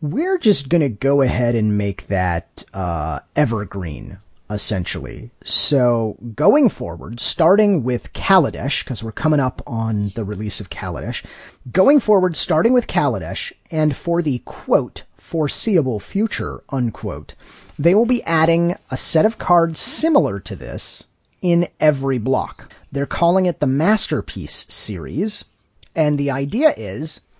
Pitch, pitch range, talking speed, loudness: 135 Hz, 105-170 Hz, 135 wpm, -19 LUFS